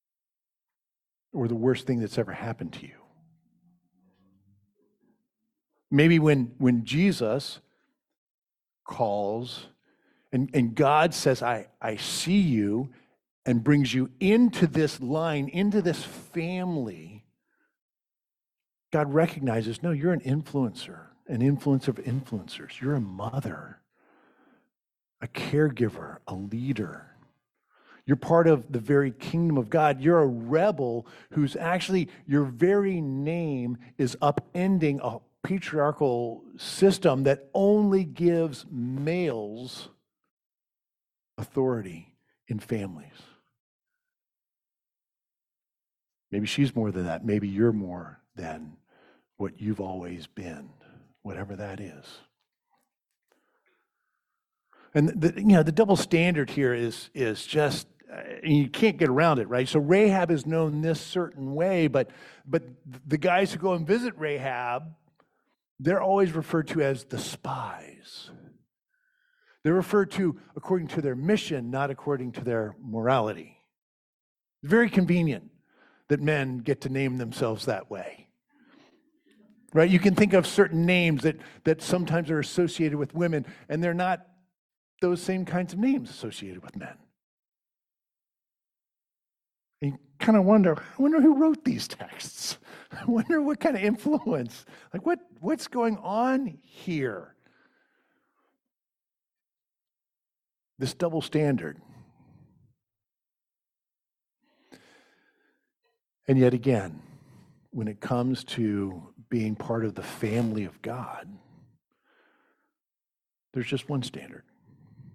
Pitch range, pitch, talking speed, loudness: 125-180 Hz, 150 Hz, 115 wpm, -26 LUFS